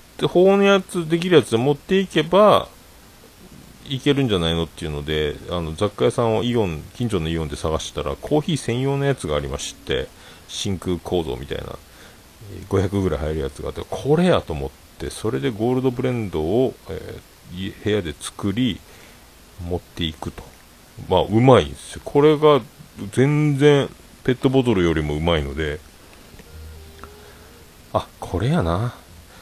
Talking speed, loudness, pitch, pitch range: 315 characters per minute, -21 LUFS, 95 Hz, 80-135 Hz